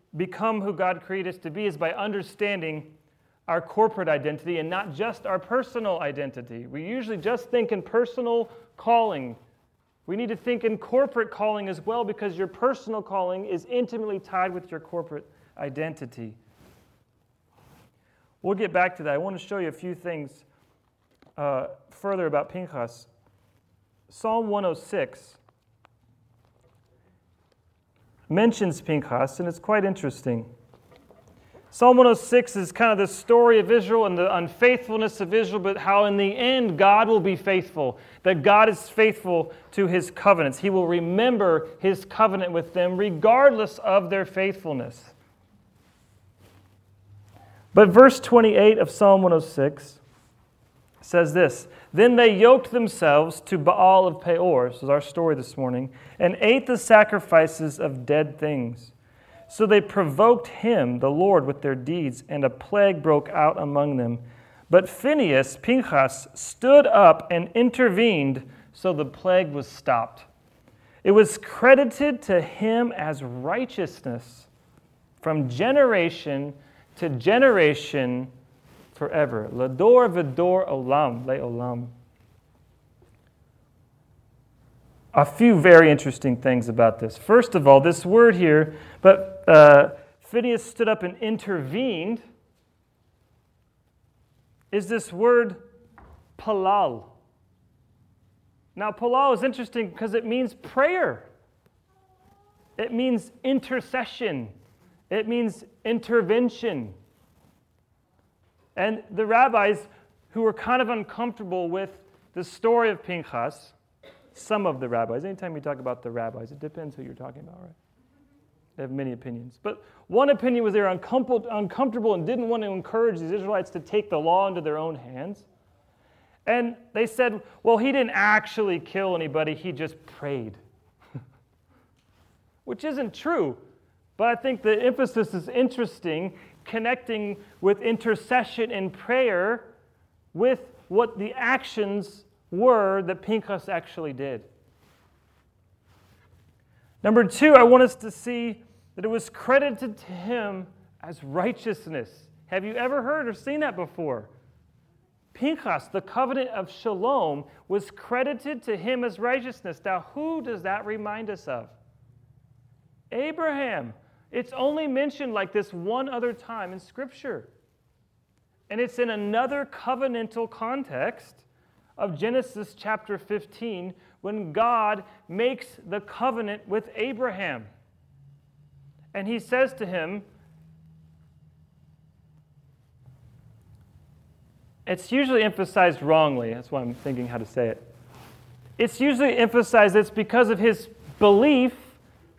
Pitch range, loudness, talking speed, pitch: 135-225 Hz, -22 LUFS, 125 wpm, 185 Hz